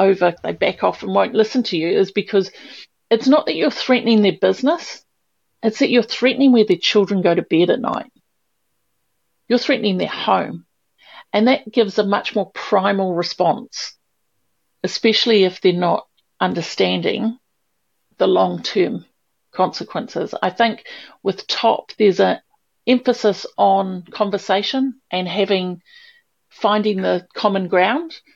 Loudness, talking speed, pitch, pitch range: -18 LUFS, 140 wpm, 210 Hz, 190-240 Hz